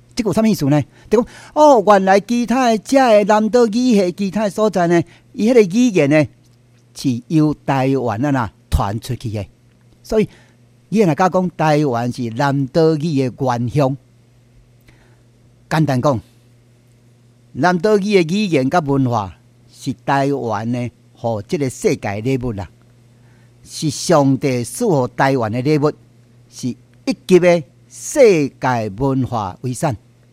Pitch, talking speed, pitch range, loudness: 130 Hz, 200 characters per minute, 120-170 Hz, -16 LUFS